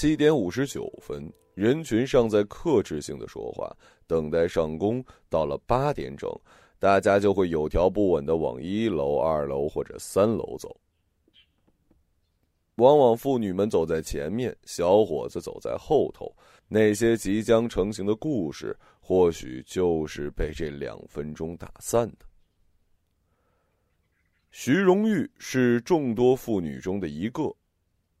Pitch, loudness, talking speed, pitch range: 100 Hz, -25 LUFS, 200 characters per minute, 80-115 Hz